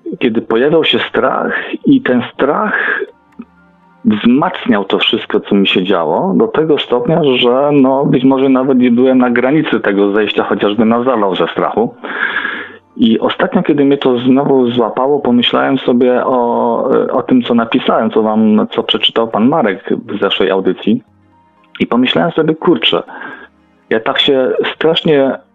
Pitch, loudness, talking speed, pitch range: 130 Hz, -12 LUFS, 150 wpm, 115-145 Hz